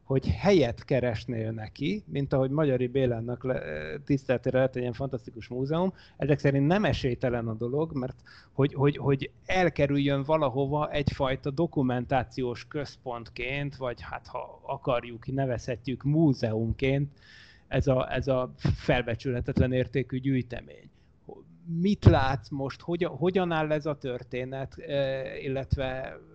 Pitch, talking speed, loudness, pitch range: 130 Hz, 115 wpm, -29 LUFS, 125-140 Hz